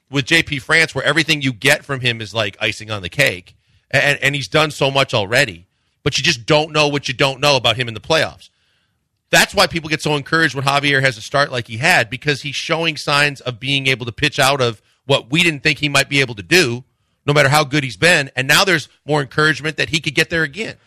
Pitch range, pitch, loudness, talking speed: 125-155 Hz, 140 Hz, -16 LUFS, 255 wpm